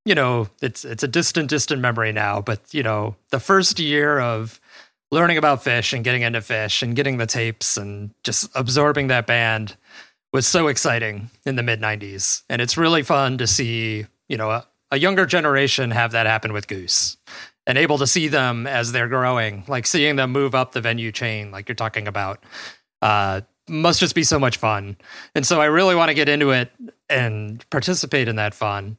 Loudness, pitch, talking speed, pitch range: -19 LUFS, 120 Hz, 200 wpm, 110-145 Hz